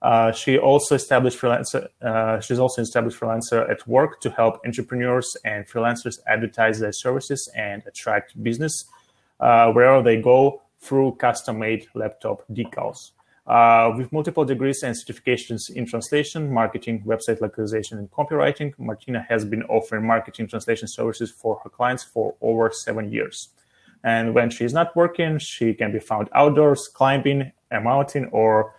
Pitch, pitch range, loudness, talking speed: 120 Hz, 115-135 Hz, -21 LUFS, 150 wpm